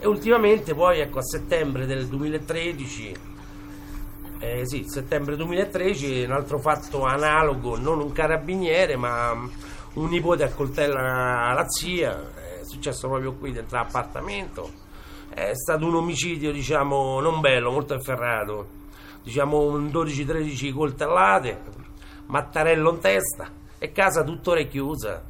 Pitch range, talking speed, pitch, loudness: 125-160 Hz, 125 wpm, 140 Hz, -24 LUFS